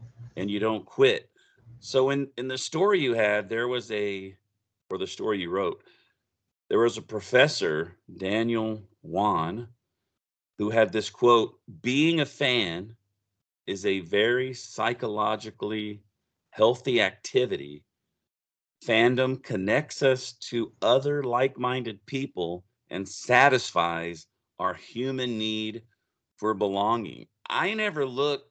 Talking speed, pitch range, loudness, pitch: 115 wpm, 105-130 Hz, -26 LUFS, 115 Hz